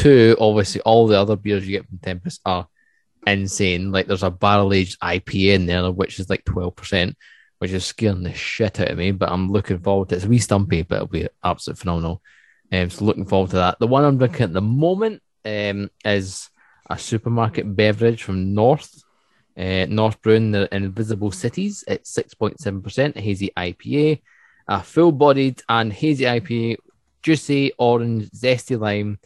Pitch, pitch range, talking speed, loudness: 105 Hz, 95-115 Hz, 180 wpm, -20 LUFS